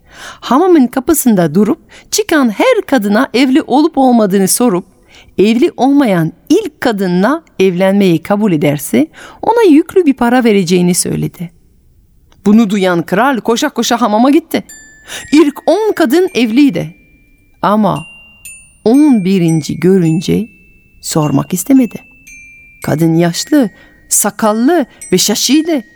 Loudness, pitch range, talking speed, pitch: -11 LUFS, 190-290 Hz, 105 wpm, 235 Hz